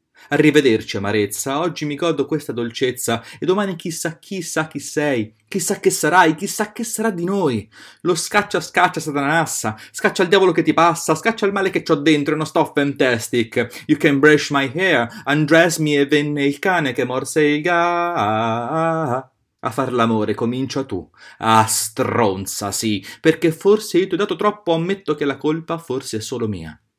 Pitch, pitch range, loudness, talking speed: 150 Hz, 125-175 Hz, -18 LUFS, 180 wpm